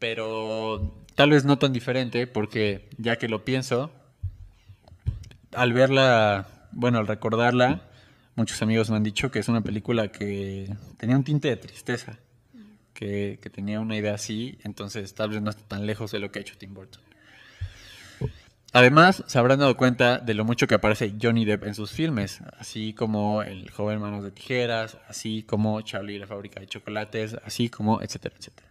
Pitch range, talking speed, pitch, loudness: 105-120 Hz, 180 wpm, 110 Hz, -25 LUFS